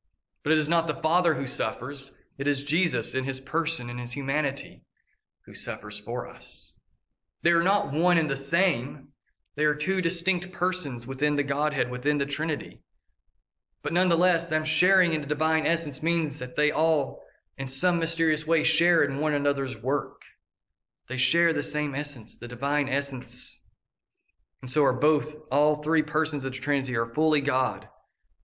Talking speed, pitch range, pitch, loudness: 170 wpm, 135-165 Hz, 150 Hz, -26 LUFS